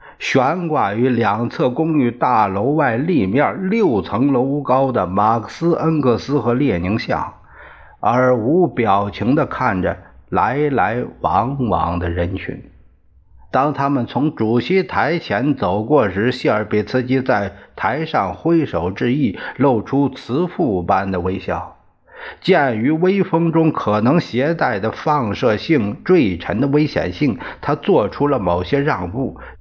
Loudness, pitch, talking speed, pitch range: -18 LUFS, 125 Hz, 200 characters per minute, 105-150 Hz